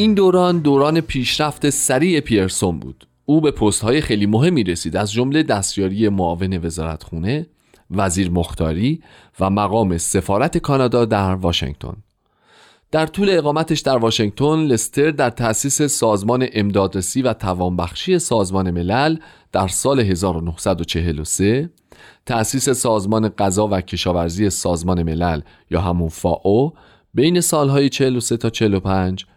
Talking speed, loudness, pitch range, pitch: 125 wpm, -18 LUFS, 90-140 Hz, 105 Hz